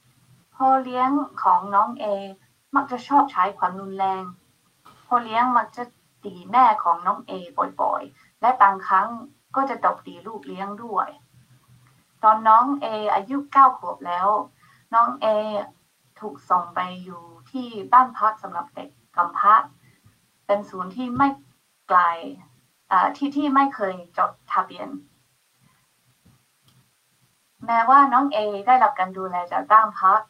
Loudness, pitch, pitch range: -21 LUFS, 210 Hz, 185-250 Hz